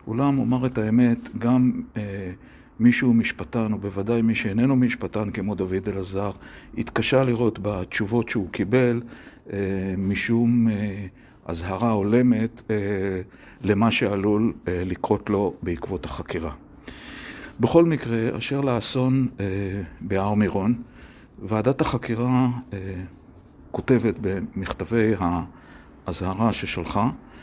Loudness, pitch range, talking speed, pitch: -24 LUFS, 100-120 Hz, 105 wpm, 110 Hz